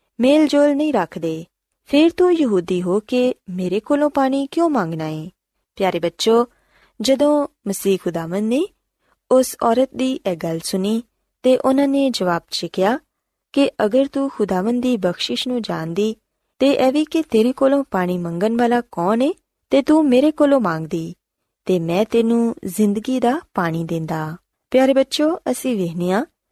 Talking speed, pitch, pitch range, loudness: 145 wpm, 235 Hz, 185-275 Hz, -19 LUFS